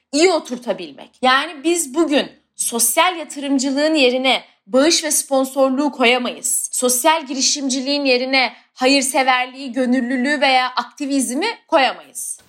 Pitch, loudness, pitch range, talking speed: 270 Hz, -17 LUFS, 255-295 Hz, 95 wpm